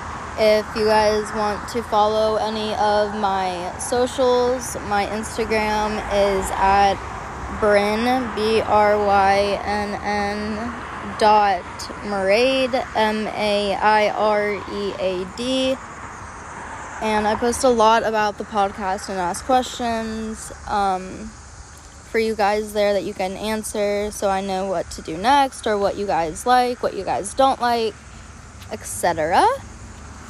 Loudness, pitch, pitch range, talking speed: -20 LUFS, 210 Hz, 200-220 Hz, 135 wpm